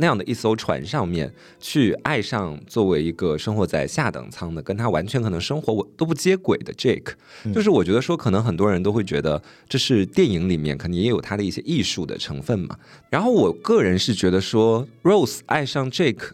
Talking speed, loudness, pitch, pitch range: 345 characters per minute, -22 LUFS, 110 Hz, 95-135 Hz